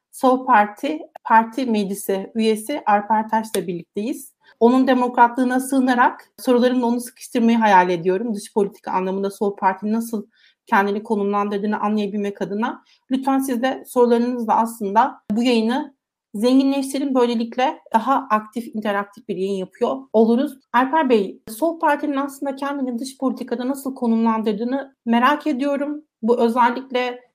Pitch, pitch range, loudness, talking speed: 240 Hz, 215-265 Hz, -20 LUFS, 125 wpm